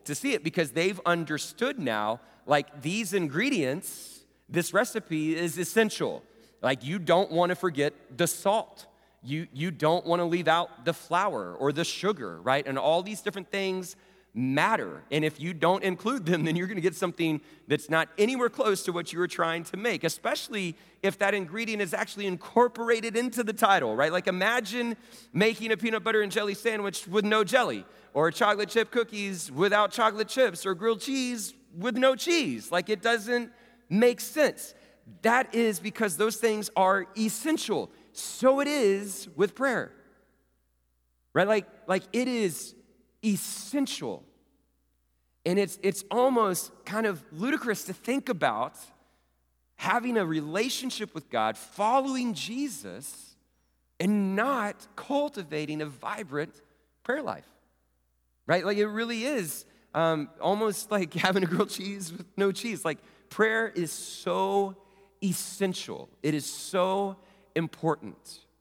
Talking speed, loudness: 150 wpm, -28 LUFS